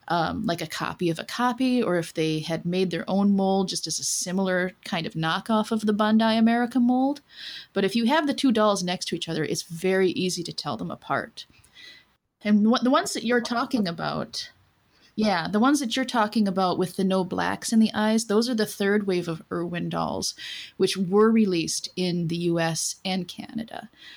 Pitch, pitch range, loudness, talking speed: 200 Hz, 175-230 Hz, -25 LUFS, 205 wpm